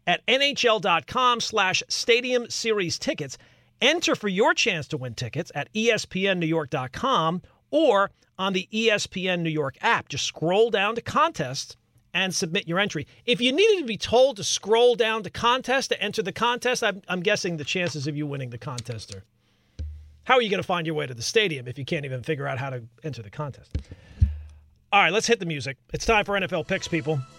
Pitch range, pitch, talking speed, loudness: 135-220 Hz, 175 Hz, 200 wpm, -24 LUFS